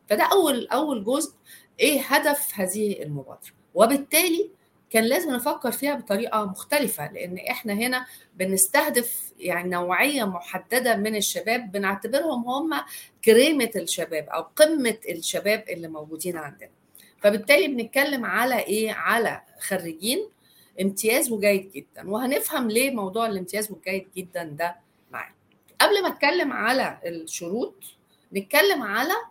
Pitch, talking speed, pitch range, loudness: 220 Hz, 120 wpm, 185-275 Hz, -23 LUFS